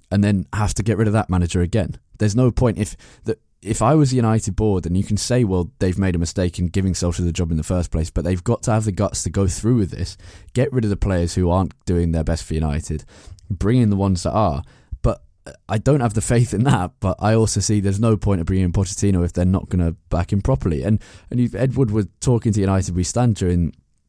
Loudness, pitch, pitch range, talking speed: -20 LUFS, 100 Hz, 90-110 Hz, 265 wpm